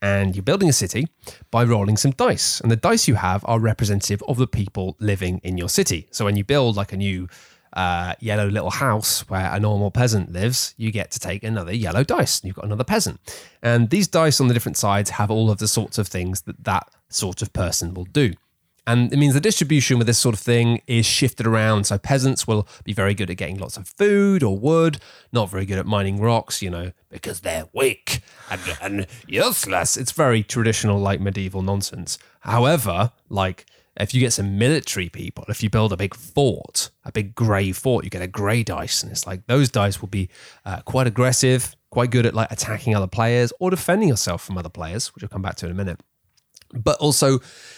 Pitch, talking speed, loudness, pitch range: 110 Hz, 220 wpm, -21 LUFS, 95-125 Hz